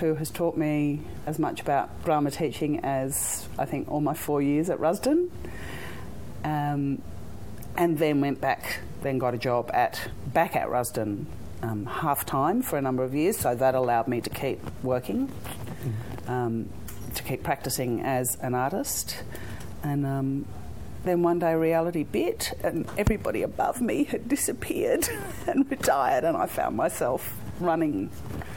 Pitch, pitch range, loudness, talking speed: 135 Hz, 120-160 Hz, -27 LUFS, 155 wpm